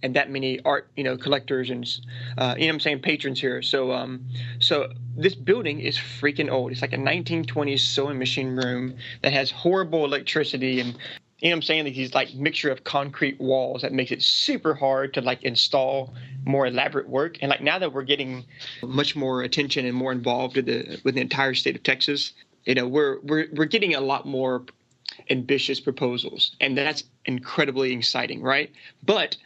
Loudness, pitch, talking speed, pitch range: -24 LUFS, 135 Hz, 195 wpm, 130-145 Hz